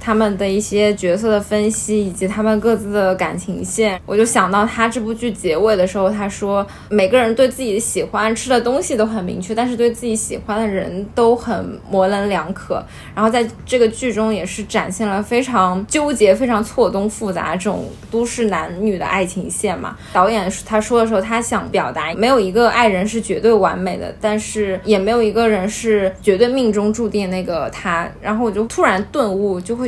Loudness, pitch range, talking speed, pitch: -17 LUFS, 195-230 Hz, 305 characters per minute, 215 Hz